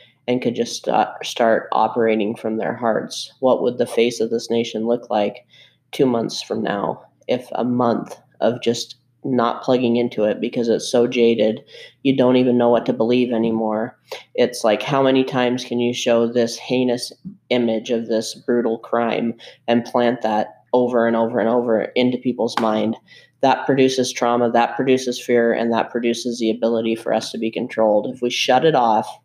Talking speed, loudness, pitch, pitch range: 185 wpm, -19 LUFS, 120 Hz, 115-125 Hz